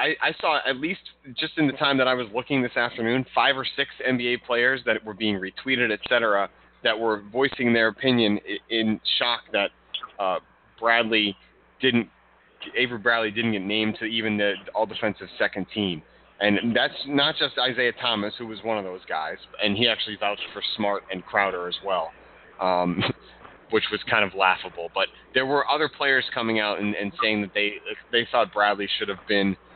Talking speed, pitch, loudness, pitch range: 190 wpm, 110 Hz, -24 LUFS, 100-120 Hz